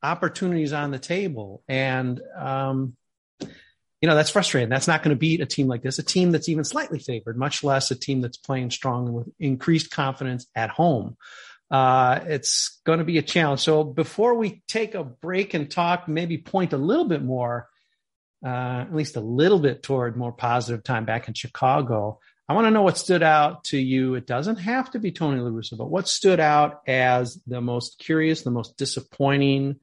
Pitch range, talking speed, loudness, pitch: 125-165 Hz, 195 wpm, -23 LUFS, 140 Hz